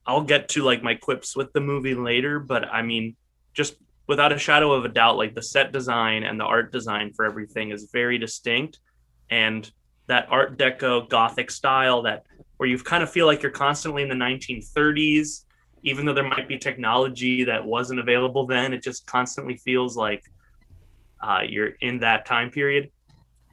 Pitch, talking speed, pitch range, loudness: 125 Hz, 185 wpm, 110-140 Hz, -23 LUFS